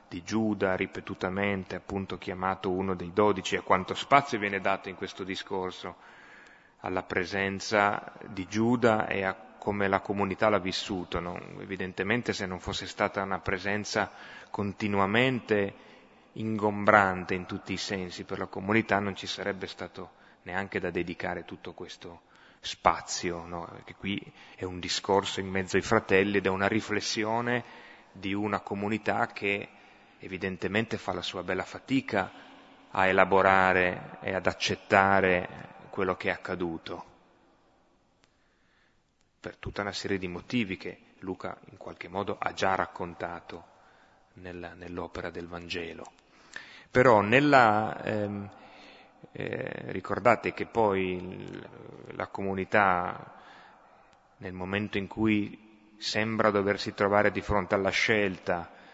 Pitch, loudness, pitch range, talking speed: 100 Hz, -29 LUFS, 95-105 Hz, 125 wpm